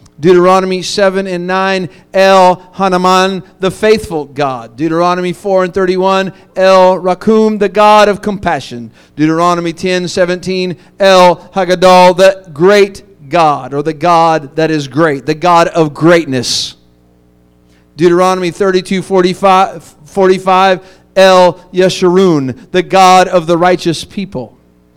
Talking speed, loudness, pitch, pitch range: 120 wpm, -10 LUFS, 180 Hz, 165-190 Hz